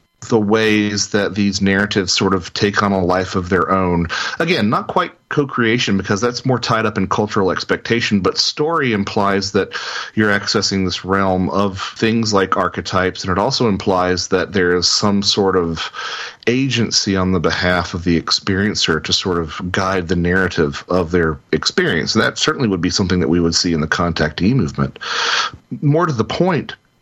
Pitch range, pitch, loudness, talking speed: 90-105 Hz, 95 Hz, -17 LUFS, 185 wpm